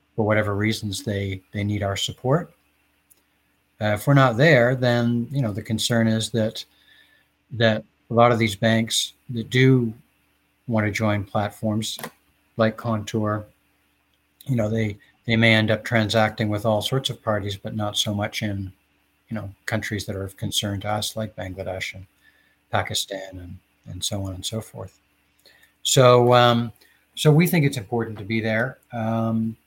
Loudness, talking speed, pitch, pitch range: -22 LUFS, 170 wpm, 110 Hz, 95-115 Hz